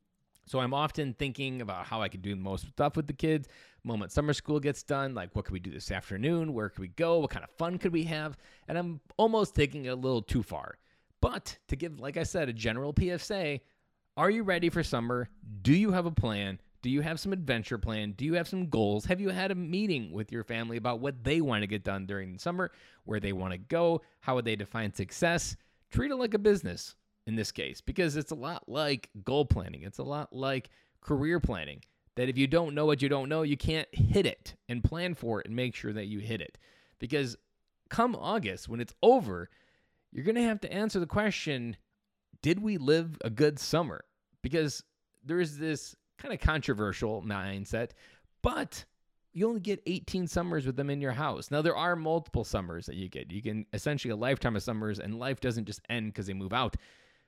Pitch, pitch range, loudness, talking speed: 135 Hz, 105-165 Hz, -32 LUFS, 225 wpm